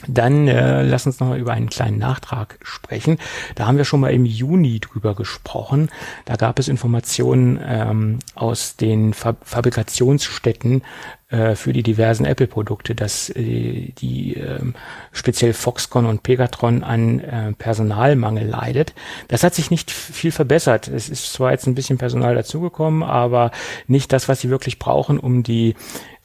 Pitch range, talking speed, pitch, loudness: 110-135 Hz, 160 wpm, 120 Hz, -19 LUFS